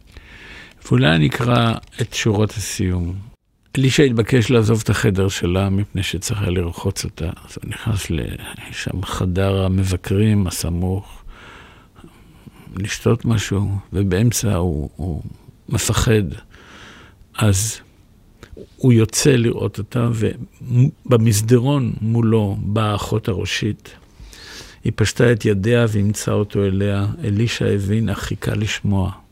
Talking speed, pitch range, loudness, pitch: 105 wpm, 95-115 Hz, -19 LUFS, 105 Hz